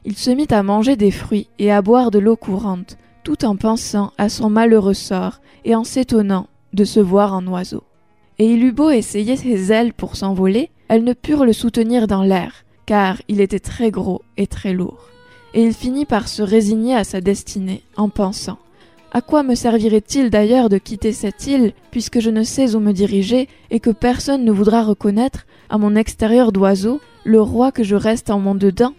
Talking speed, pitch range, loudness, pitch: 200 wpm, 205-240 Hz, -16 LUFS, 220 Hz